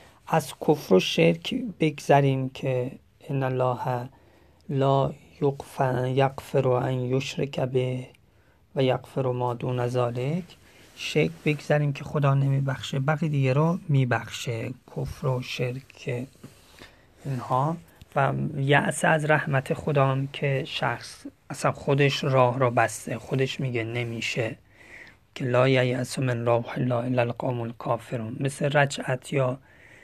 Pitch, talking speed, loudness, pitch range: 130 Hz, 120 wpm, -26 LUFS, 125-140 Hz